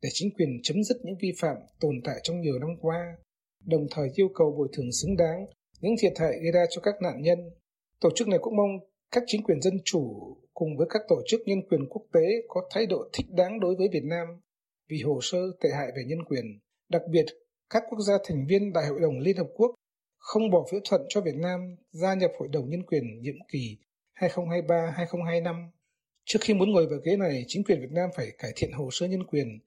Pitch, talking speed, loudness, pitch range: 175 Hz, 230 wpm, -28 LUFS, 155-195 Hz